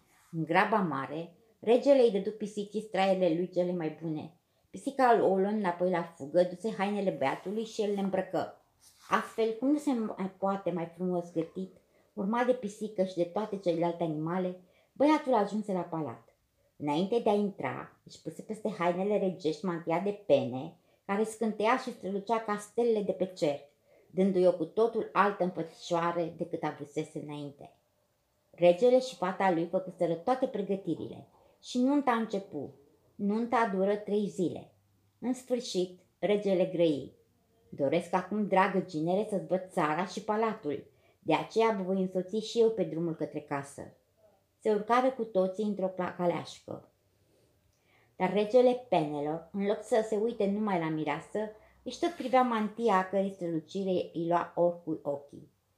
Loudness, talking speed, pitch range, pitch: -31 LUFS, 155 wpm, 170-215 Hz, 185 Hz